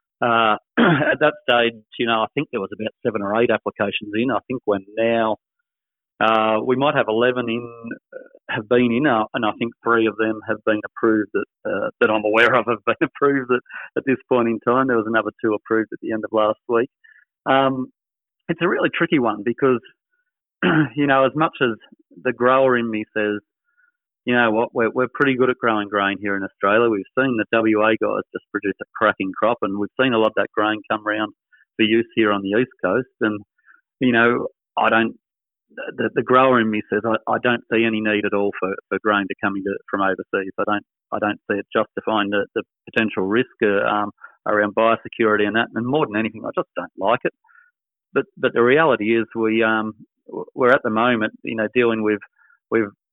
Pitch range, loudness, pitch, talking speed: 105-125 Hz, -20 LUFS, 115 Hz, 215 wpm